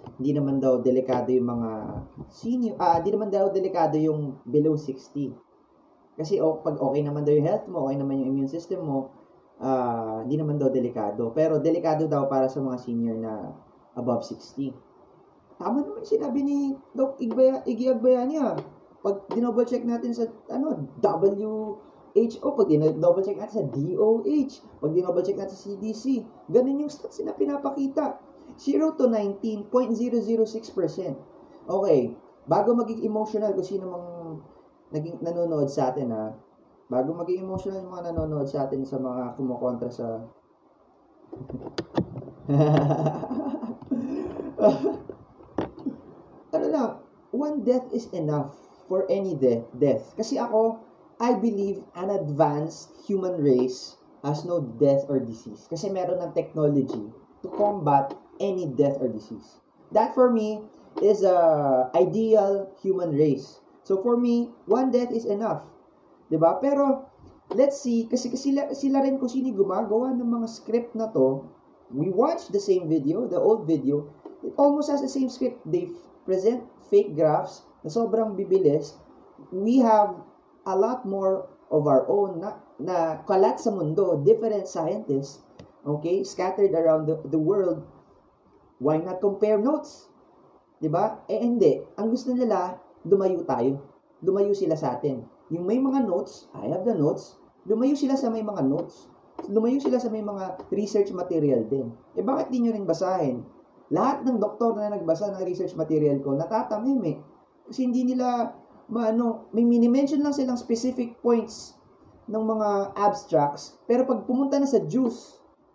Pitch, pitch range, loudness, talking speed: 200 Hz, 150-240 Hz, -25 LUFS, 150 wpm